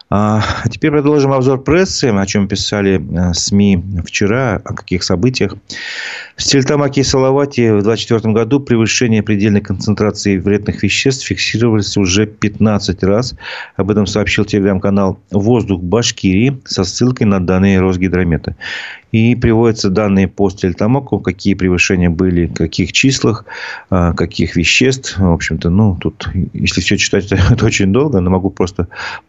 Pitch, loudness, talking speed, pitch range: 100 Hz, -13 LUFS, 135 wpm, 95-115 Hz